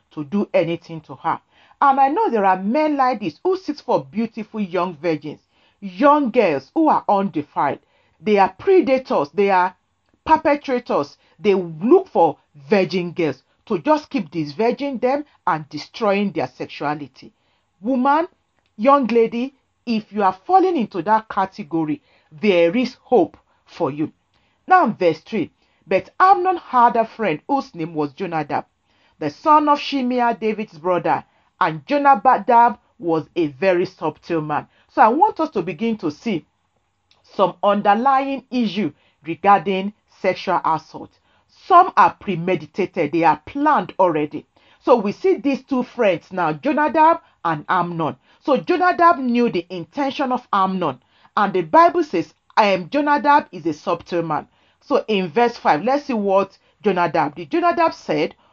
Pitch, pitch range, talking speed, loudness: 205 Hz, 170-275 Hz, 150 wpm, -19 LUFS